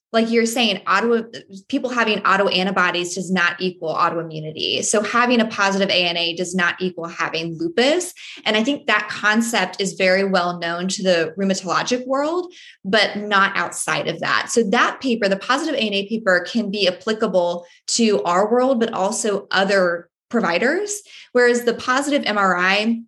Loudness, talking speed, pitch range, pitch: -19 LUFS, 160 wpm, 180-235 Hz, 200 Hz